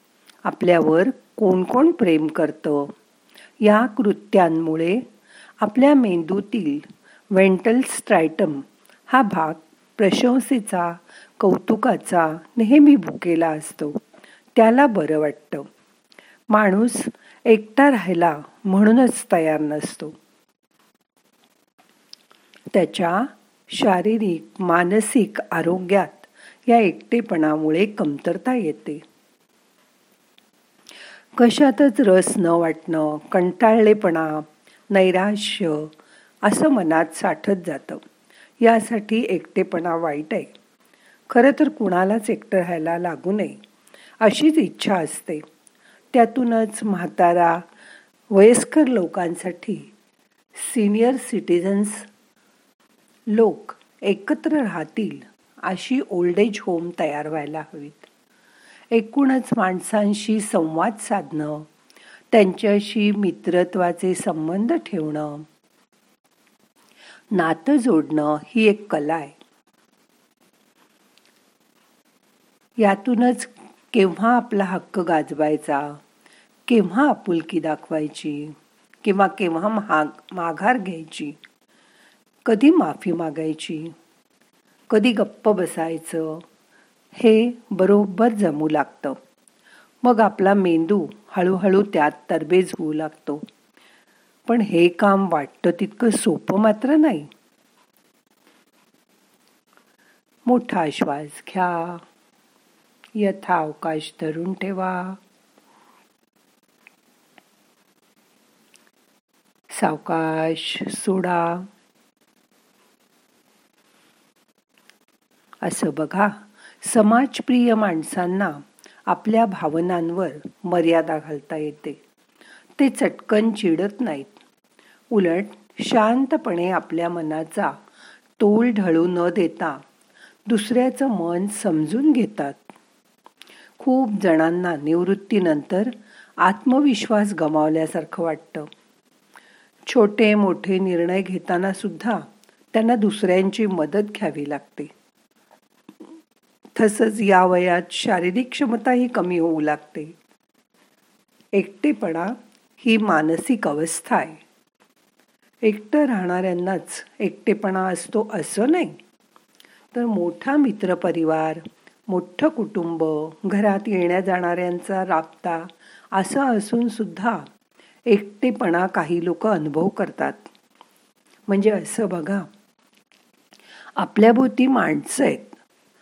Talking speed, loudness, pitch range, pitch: 75 wpm, -20 LUFS, 170-230 Hz, 195 Hz